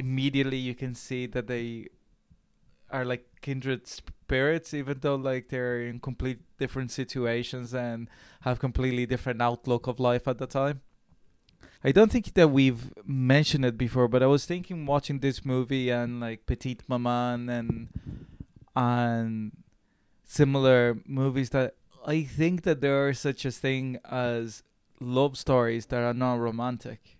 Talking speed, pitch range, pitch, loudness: 150 wpm, 120-135 Hz, 130 Hz, -28 LUFS